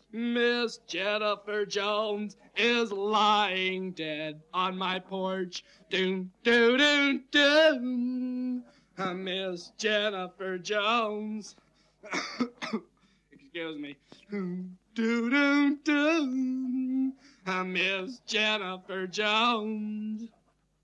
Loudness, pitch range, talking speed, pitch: -28 LUFS, 185-240 Hz, 75 wpm, 210 Hz